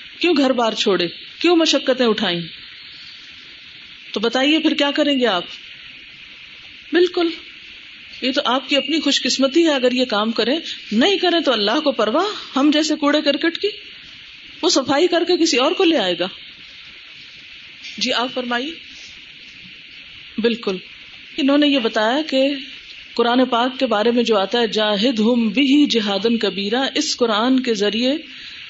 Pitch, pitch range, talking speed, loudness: 265 Hz, 230-300 Hz, 155 wpm, -18 LUFS